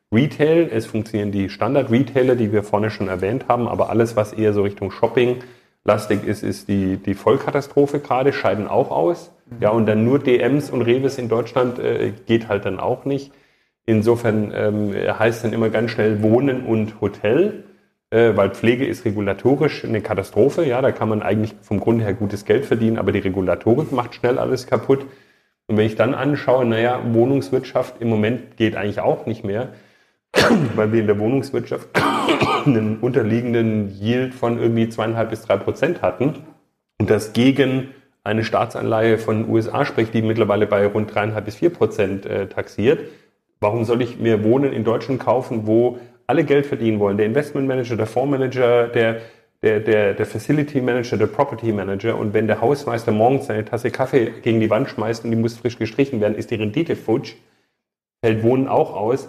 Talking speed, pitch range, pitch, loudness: 180 wpm, 110-125 Hz, 115 Hz, -19 LUFS